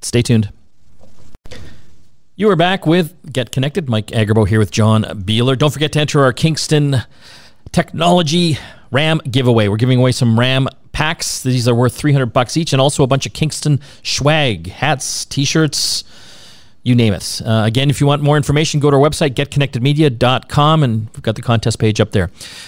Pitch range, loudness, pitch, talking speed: 115-150 Hz, -15 LUFS, 135 Hz, 175 wpm